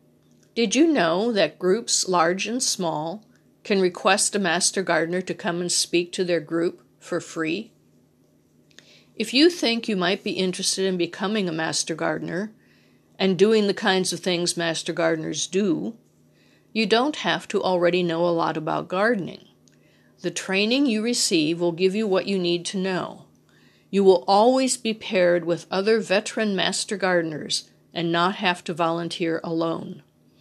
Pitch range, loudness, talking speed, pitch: 170-205 Hz, -23 LUFS, 160 wpm, 185 Hz